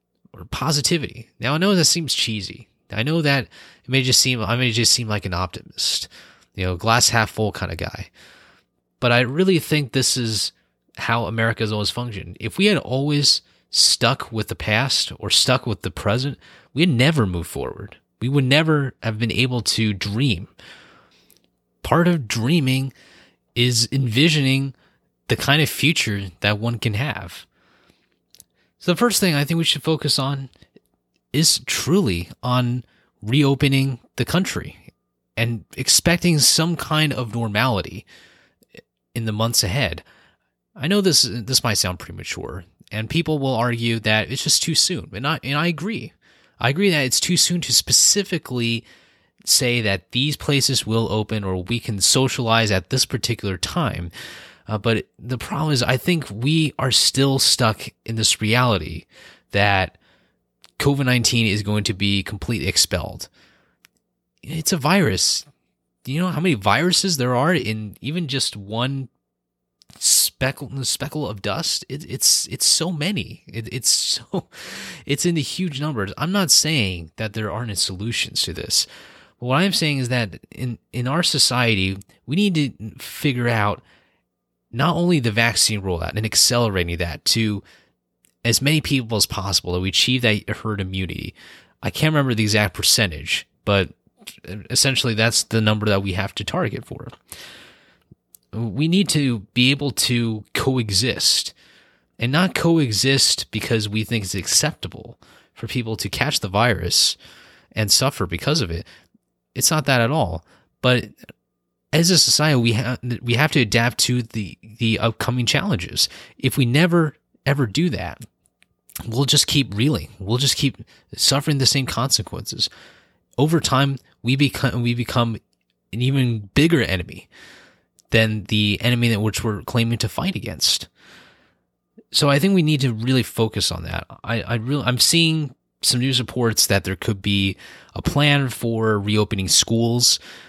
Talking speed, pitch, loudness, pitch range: 160 wpm, 120 Hz, -19 LUFS, 105-140 Hz